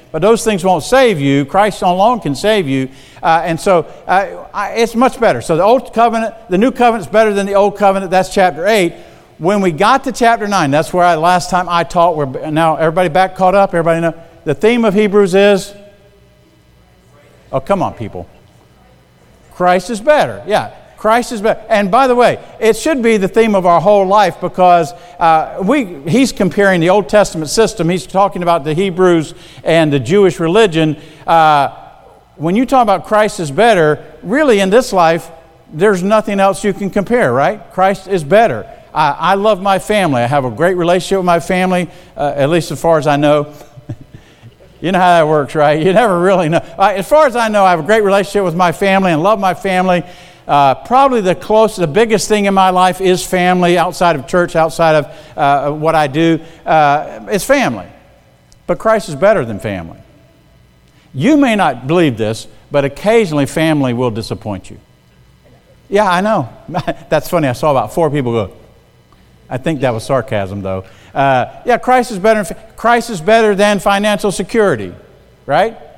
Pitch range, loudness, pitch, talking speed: 155-210 Hz, -12 LUFS, 180 Hz, 195 wpm